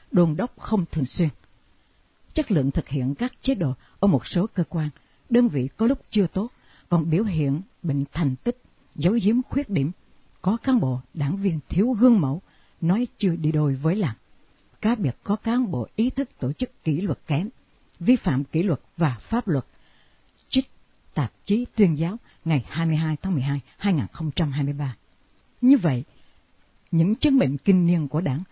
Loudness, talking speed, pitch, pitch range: -24 LUFS, 180 wpm, 165 Hz, 140-210 Hz